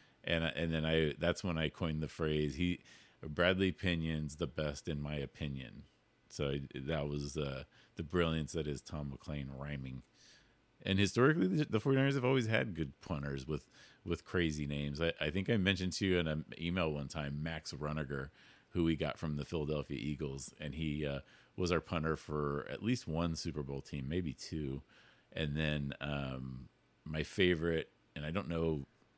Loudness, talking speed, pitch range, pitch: -37 LUFS, 180 wpm, 70-85 Hz, 80 Hz